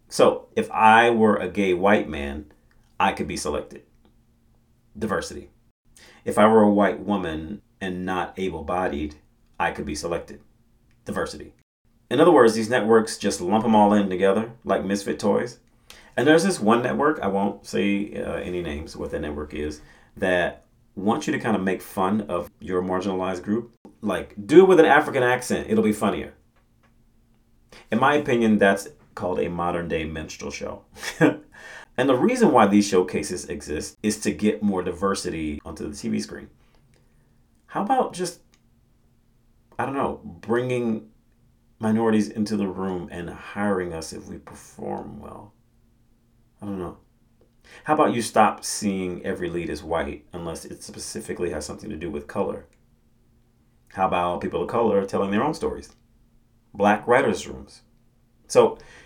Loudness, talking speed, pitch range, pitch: -23 LUFS, 160 wpm, 90-115 Hz, 105 Hz